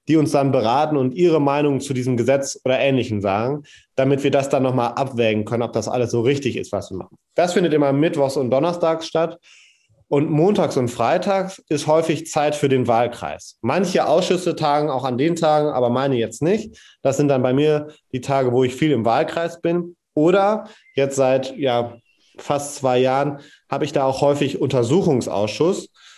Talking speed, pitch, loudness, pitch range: 190 wpm, 140 Hz, -19 LUFS, 130-155 Hz